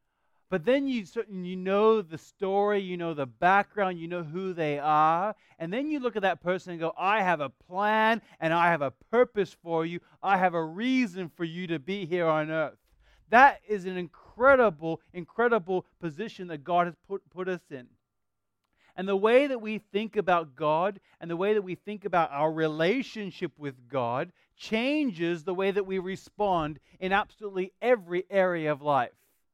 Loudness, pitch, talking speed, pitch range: -28 LUFS, 185 Hz, 185 wpm, 165-205 Hz